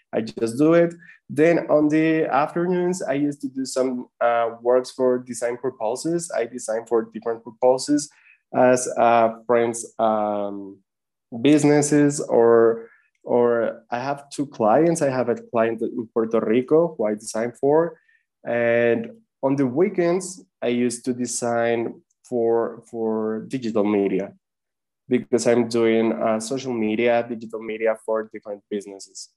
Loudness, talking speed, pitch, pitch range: -22 LUFS, 140 wpm, 120 Hz, 115-145 Hz